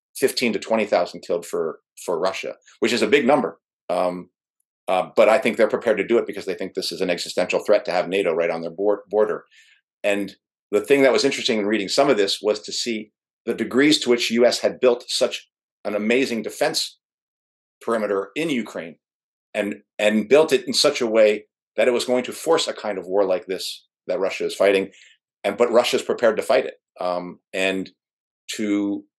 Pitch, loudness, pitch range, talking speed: 110 Hz, -21 LUFS, 100-135 Hz, 205 wpm